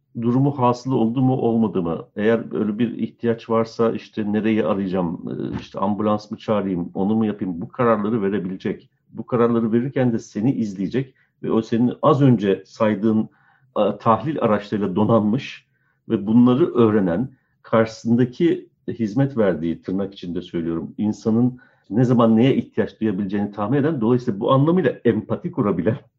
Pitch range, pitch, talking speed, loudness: 105-125 Hz, 115 Hz, 140 wpm, -21 LUFS